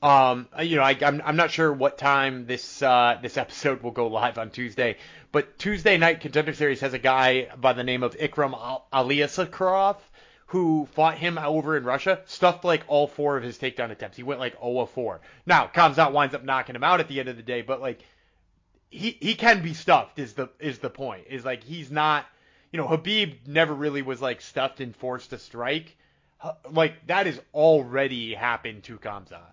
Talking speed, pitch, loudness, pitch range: 205 wpm, 140 Hz, -24 LUFS, 125-160 Hz